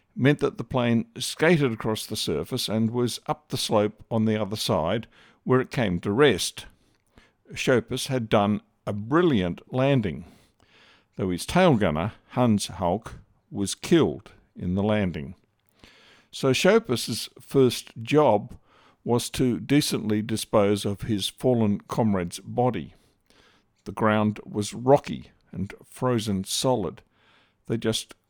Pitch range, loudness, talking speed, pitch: 105-130 Hz, -25 LUFS, 130 wpm, 115 Hz